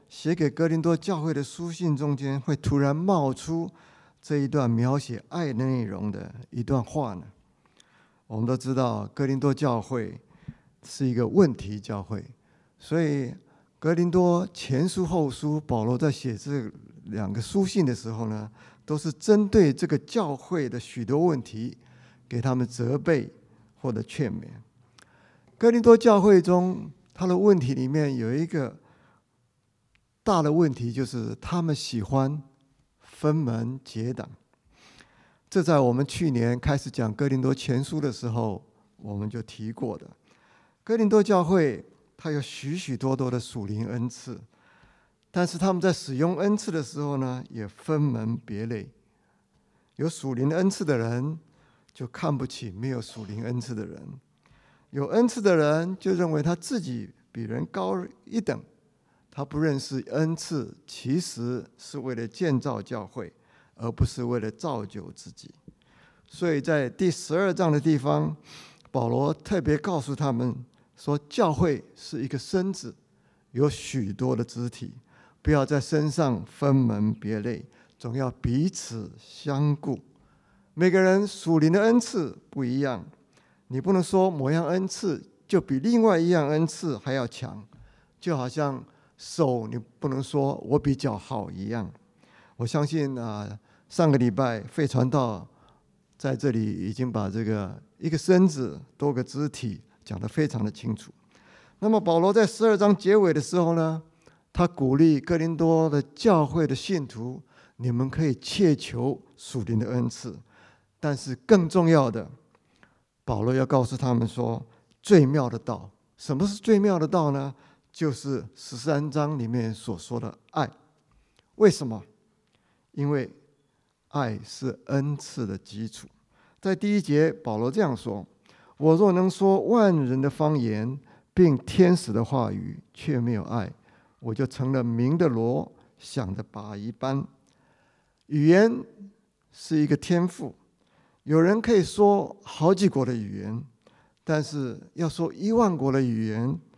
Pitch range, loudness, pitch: 120-165 Hz, -26 LUFS, 140 Hz